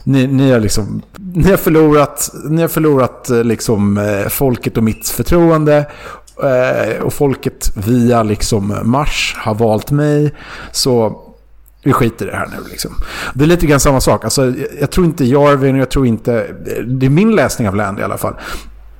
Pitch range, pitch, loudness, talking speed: 110-145 Hz, 130 Hz, -13 LUFS, 165 wpm